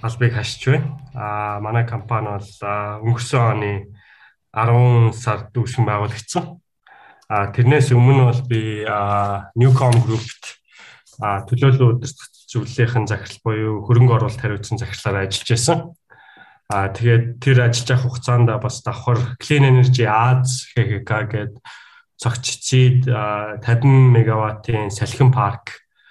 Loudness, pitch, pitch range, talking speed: -18 LUFS, 120 Hz, 110-125 Hz, 120 wpm